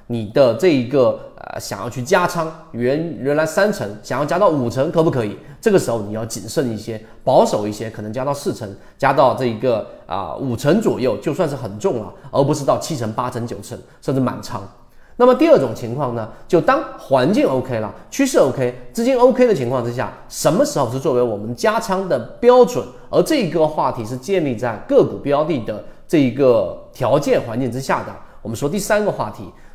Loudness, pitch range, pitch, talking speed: -18 LUFS, 115-170 Hz, 130 Hz, 305 characters per minute